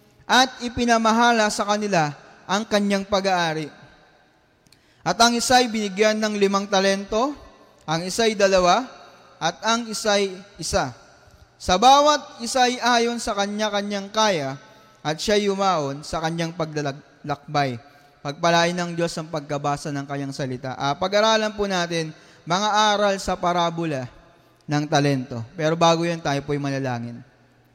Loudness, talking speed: -21 LUFS, 125 wpm